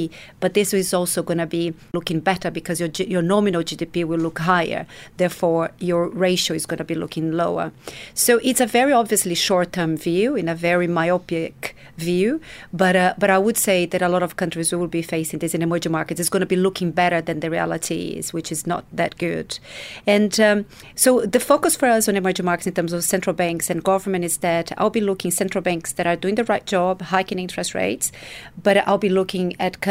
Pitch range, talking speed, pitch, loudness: 170-195 Hz, 225 wpm, 180 Hz, -20 LUFS